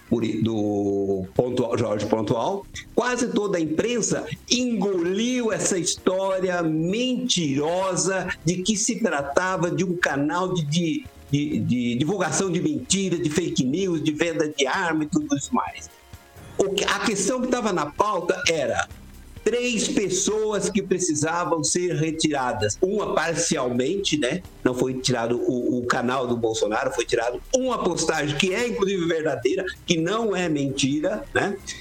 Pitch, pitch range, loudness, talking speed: 170 Hz, 140-195 Hz, -23 LUFS, 140 wpm